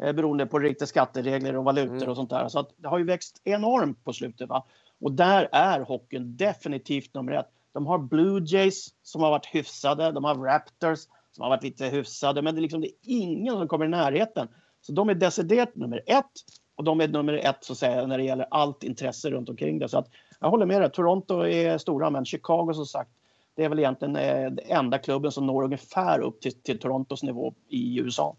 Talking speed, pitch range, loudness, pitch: 220 wpm, 130-170 Hz, -26 LUFS, 145 Hz